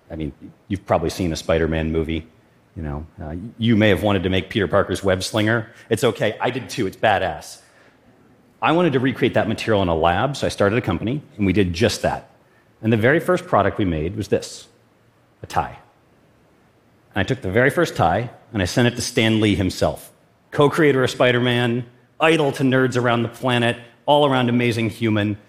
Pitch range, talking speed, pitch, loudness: 95-125 Hz, 200 wpm, 115 Hz, -20 LUFS